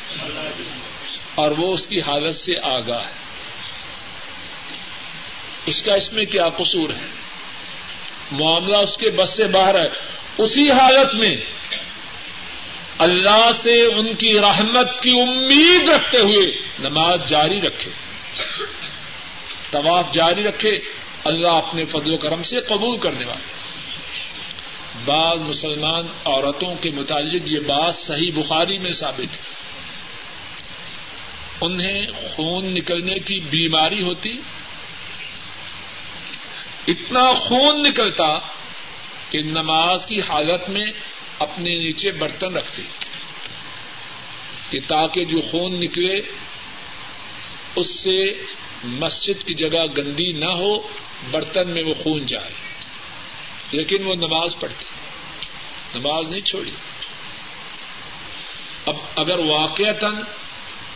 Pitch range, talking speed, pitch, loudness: 155-210 Hz, 105 wpm, 175 Hz, -17 LUFS